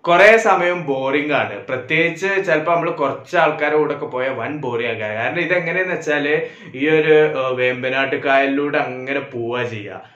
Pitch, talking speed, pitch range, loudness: 150 Hz, 130 wpm, 130-170 Hz, -18 LUFS